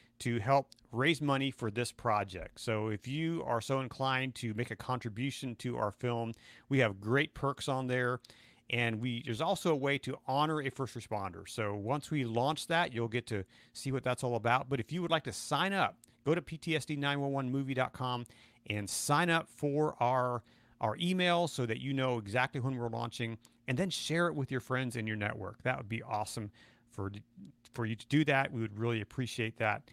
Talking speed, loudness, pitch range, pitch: 205 wpm, -34 LUFS, 115-140 Hz, 125 Hz